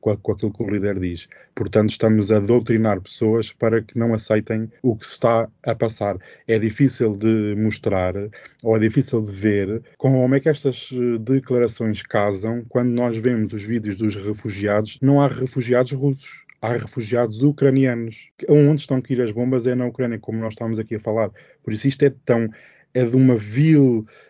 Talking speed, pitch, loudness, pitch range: 185 wpm, 115 Hz, -20 LUFS, 110-125 Hz